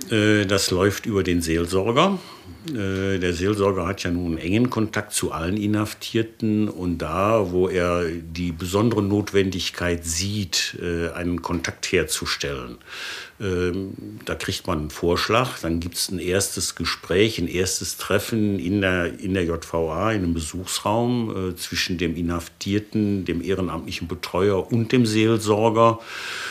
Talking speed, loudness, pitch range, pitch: 130 wpm, -23 LUFS, 85-105 Hz, 95 Hz